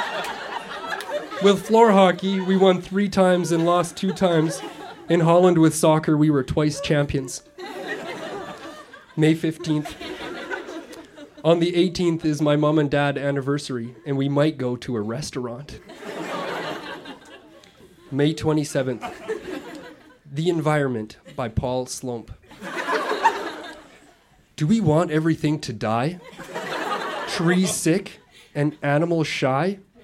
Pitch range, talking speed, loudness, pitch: 140-180 Hz, 110 wpm, -22 LUFS, 155 Hz